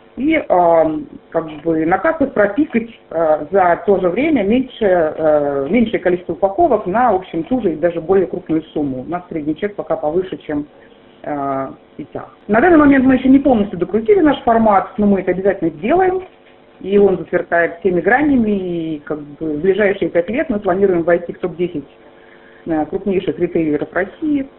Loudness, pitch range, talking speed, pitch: -16 LUFS, 160-215 Hz, 170 wpm, 180 Hz